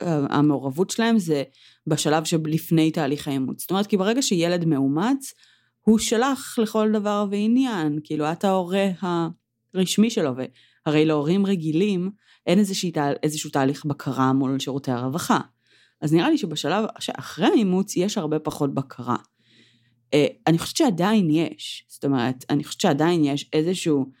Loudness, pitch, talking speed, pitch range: -23 LUFS, 160 Hz, 135 wpm, 145-195 Hz